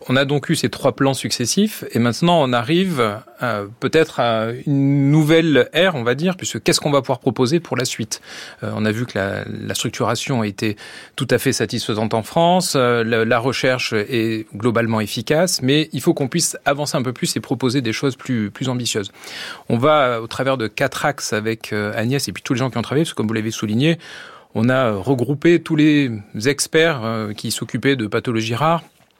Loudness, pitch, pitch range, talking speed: -19 LUFS, 130 Hz, 115-145 Hz, 220 wpm